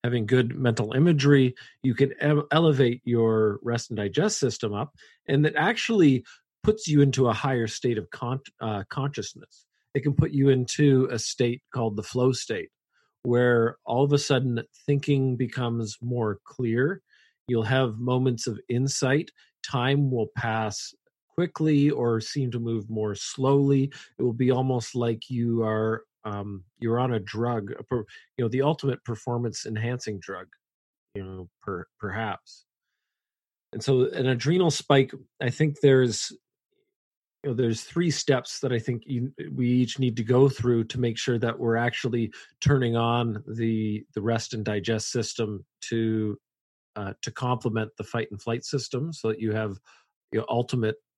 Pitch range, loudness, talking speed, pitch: 115-135 Hz, -26 LUFS, 160 wpm, 125 Hz